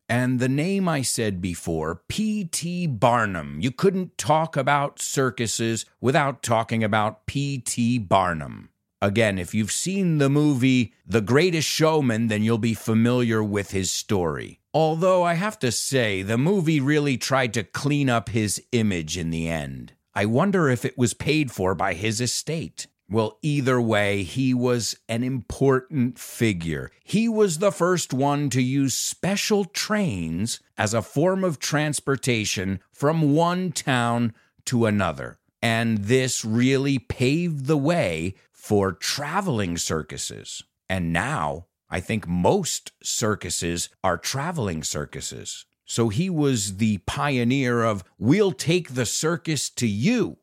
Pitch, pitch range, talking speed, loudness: 120 Hz, 105-145 Hz, 140 wpm, -23 LUFS